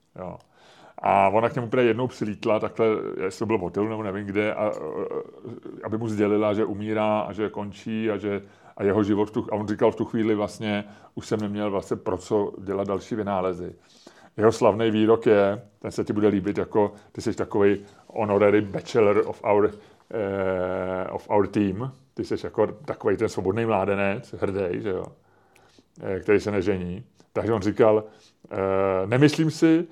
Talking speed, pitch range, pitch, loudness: 175 wpm, 100-110 Hz, 105 Hz, -24 LUFS